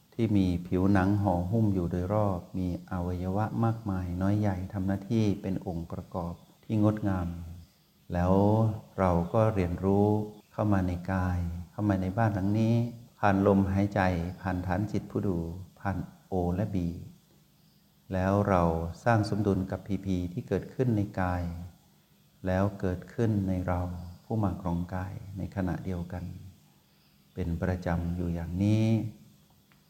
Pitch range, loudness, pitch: 90-105 Hz, -30 LUFS, 95 Hz